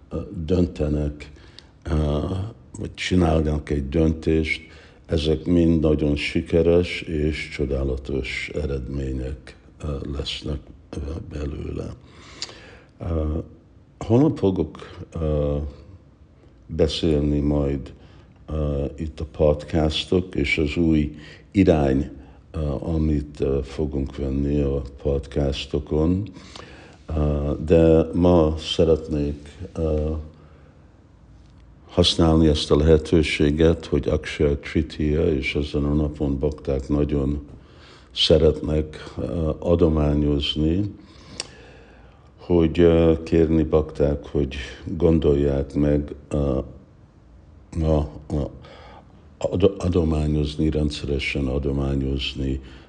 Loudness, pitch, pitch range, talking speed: -22 LUFS, 75 Hz, 70-80 Hz, 65 wpm